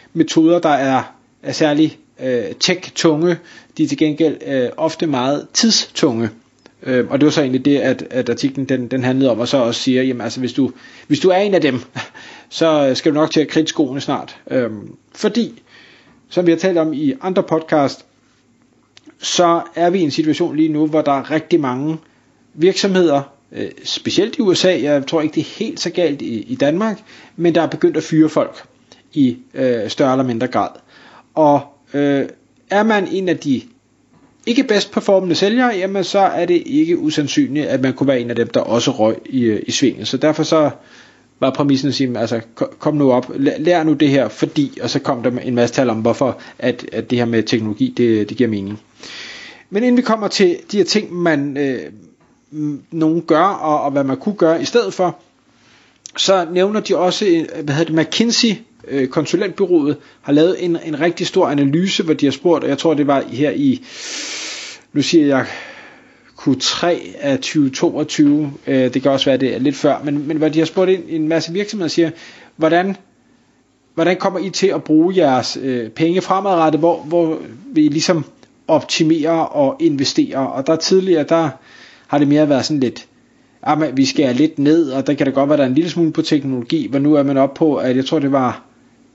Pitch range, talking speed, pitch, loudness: 140-185 Hz, 205 wpm, 160 Hz, -16 LUFS